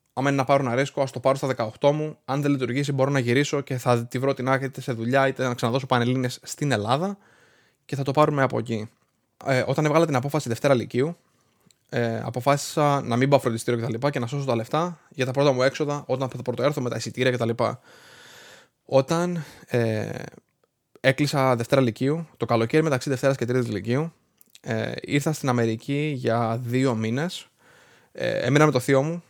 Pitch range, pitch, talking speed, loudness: 125-145 Hz, 135 Hz, 195 wpm, -24 LUFS